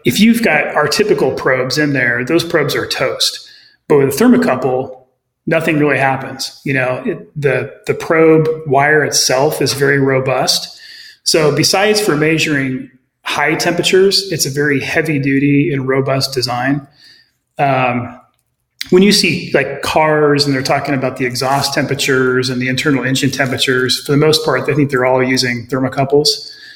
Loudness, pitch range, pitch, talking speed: -13 LUFS, 130-165 Hz, 140 Hz, 160 wpm